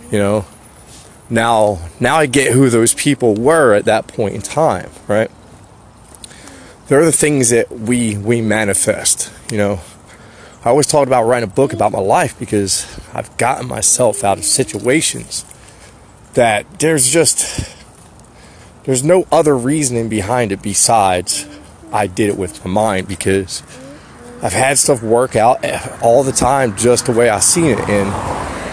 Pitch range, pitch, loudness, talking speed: 100-135 Hz, 115 Hz, -14 LUFS, 155 wpm